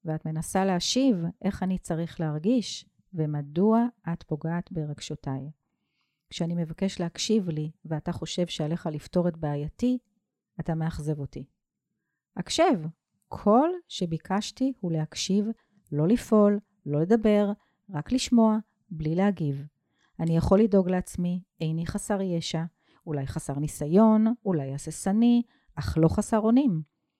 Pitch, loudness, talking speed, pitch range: 175 Hz, -27 LUFS, 115 wpm, 160-210 Hz